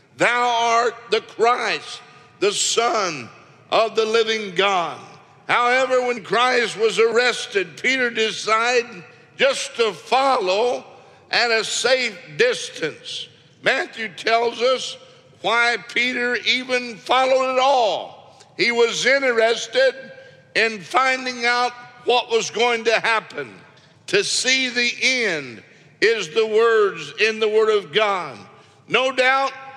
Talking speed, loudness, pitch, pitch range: 115 wpm, -19 LUFS, 245 Hz, 230-270 Hz